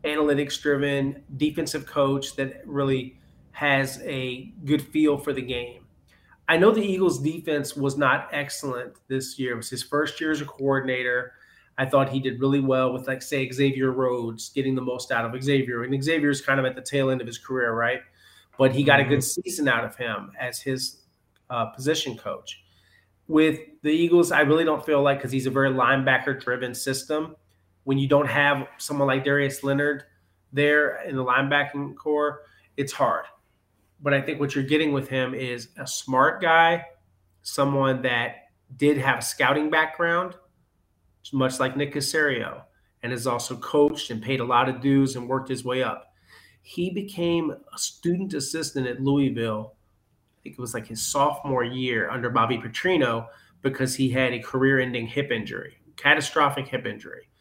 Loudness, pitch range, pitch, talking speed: -24 LUFS, 125-145 Hz, 135 Hz, 180 wpm